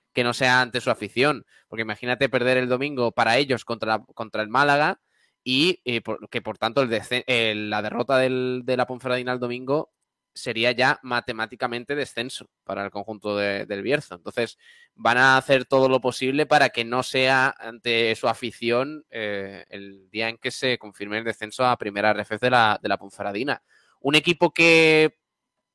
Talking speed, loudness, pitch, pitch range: 185 wpm, -23 LUFS, 125 Hz, 110-130 Hz